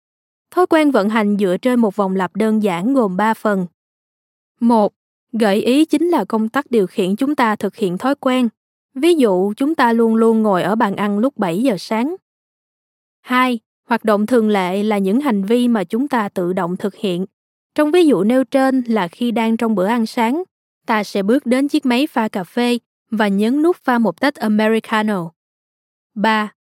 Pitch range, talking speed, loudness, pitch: 205-255 Hz, 200 wpm, -17 LUFS, 225 Hz